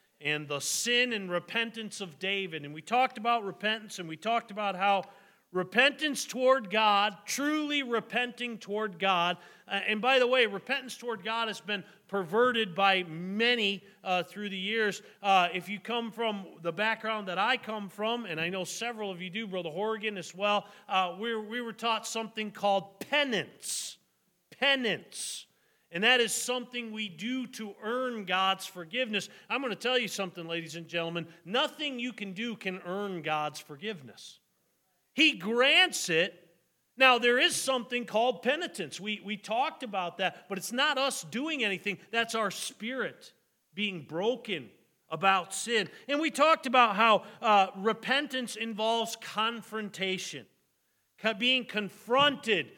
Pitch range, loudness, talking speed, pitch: 190-240 Hz, -29 LUFS, 155 wpm, 215 Hz